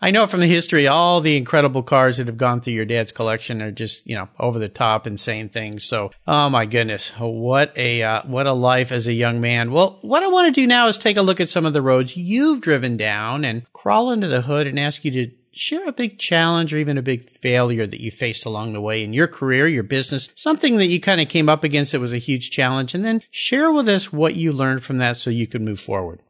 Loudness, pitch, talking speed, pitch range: -19 LUFS, 135 Hz, 260 wpm, 115-170 Hz